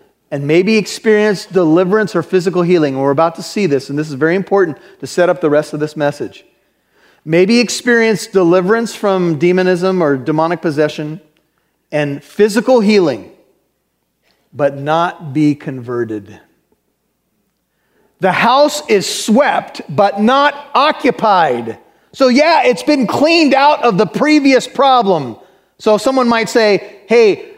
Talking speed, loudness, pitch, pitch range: 135 wpm, -13 LUFS, 190 Hz, 155-235 Hz